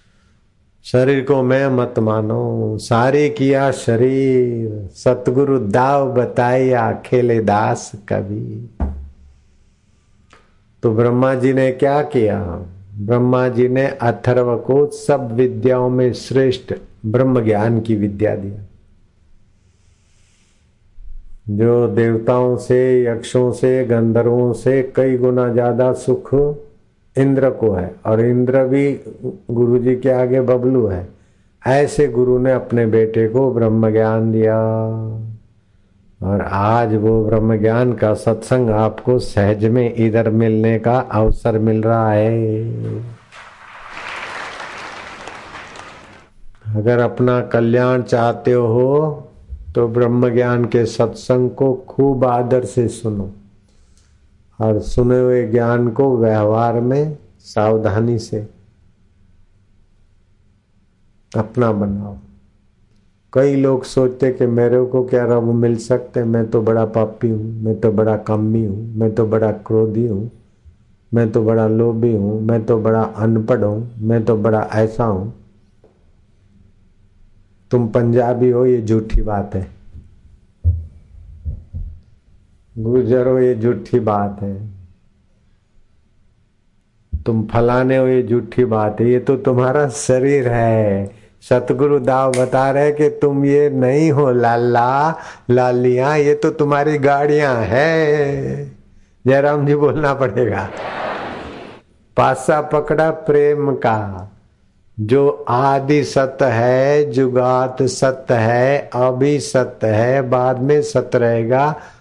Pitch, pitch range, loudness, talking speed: 115 Hz, 105-125 Hz, -16 LUFS, 110 wpm